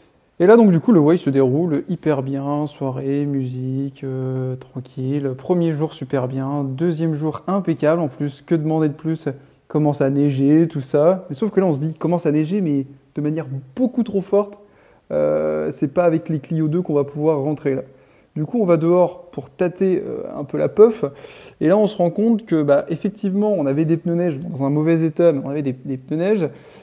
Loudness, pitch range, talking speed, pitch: -19 LUFS, 140-175 Hz, 220 wpm, 155 Hz